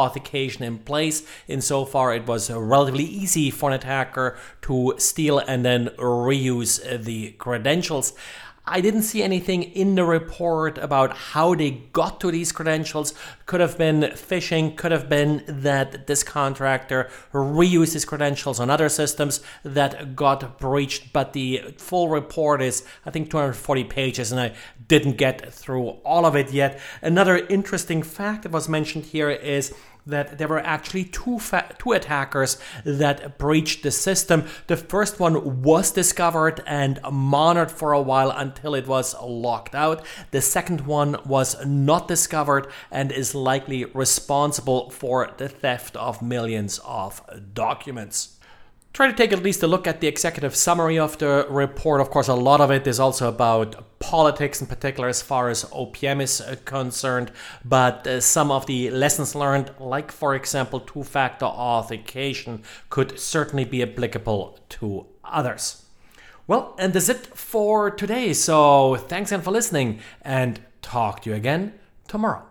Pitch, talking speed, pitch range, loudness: 140 Hz, 155 wpm, 130-160 Hz, -22 LUFS